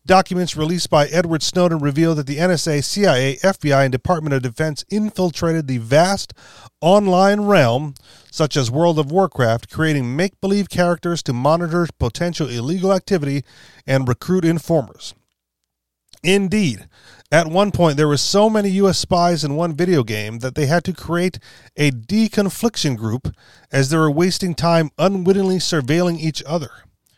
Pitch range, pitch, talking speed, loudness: 140-180 Hz, 165 Hz, 150 wpm, -18 LUFS